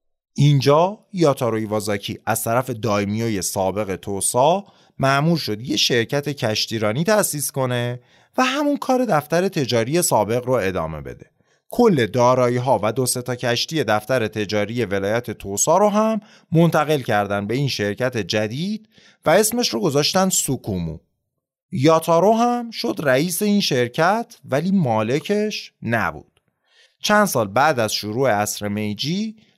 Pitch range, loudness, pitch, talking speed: 110-175 Hz, -20 LUFS, 130 Hz, 130 wpm